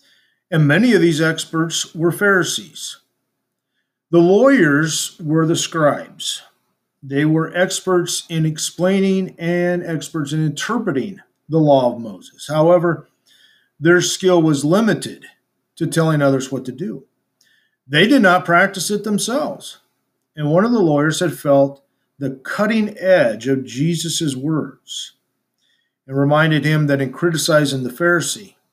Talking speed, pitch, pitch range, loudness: 130 wpm, 160 Hz, 145-180 Hz, -17 LUFS